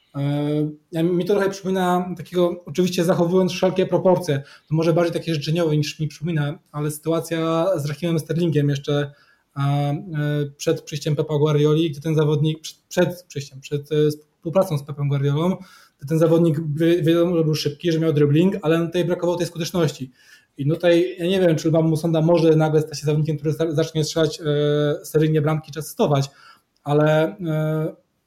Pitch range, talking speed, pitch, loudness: 150-170 Hz, 160 wpm, 160 Hz, -21 LUFS